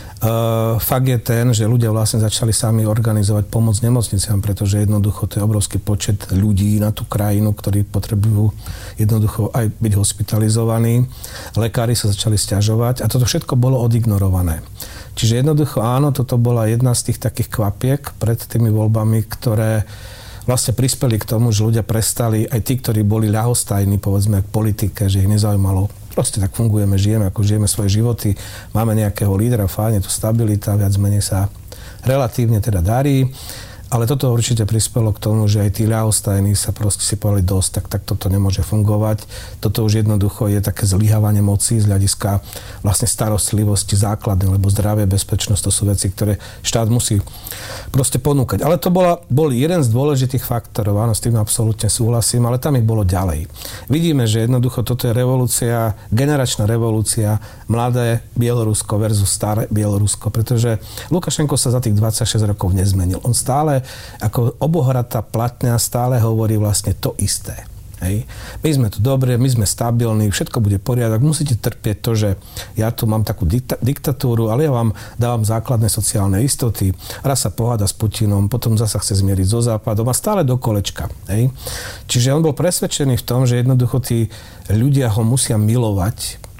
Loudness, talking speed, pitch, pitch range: -17 LUFS, 165 wpm, 110 Hz, 105-120 Hz